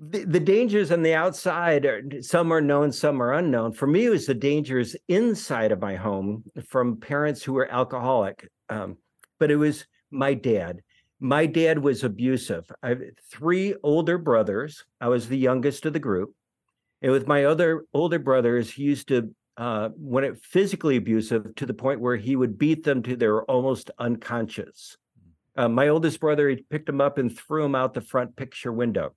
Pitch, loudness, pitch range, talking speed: 135 Hz, -24 LUFS, 125-155 Hz, 190 wpm